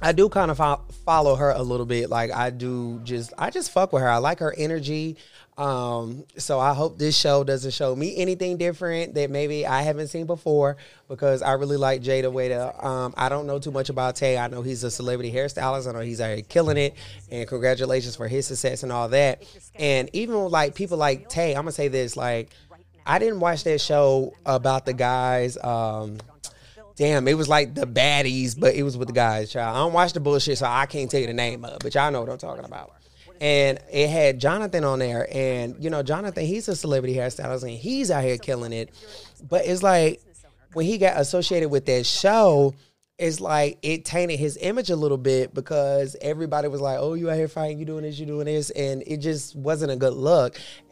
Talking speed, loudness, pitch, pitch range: 225 wpm, -23 LUFS, 140 Hz, 130-155 Hz